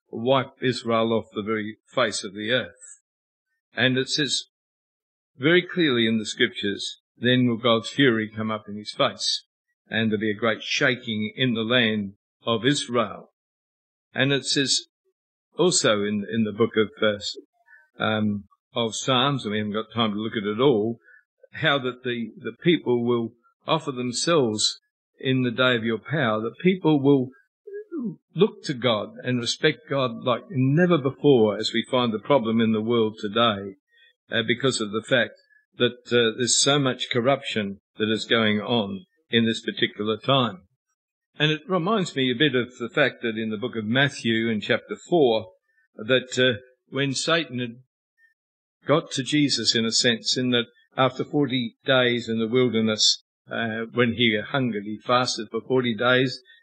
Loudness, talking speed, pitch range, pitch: -23 LUFS, 170 wpm, 115-145 Hz, 125 Hz